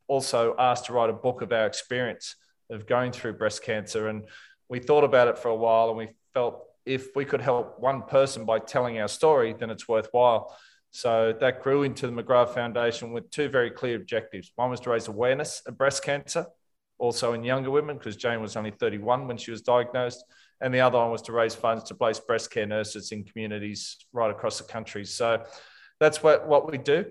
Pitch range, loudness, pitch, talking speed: 110-130 Hz, -26 LUFS, 120 Hz, 215 wpm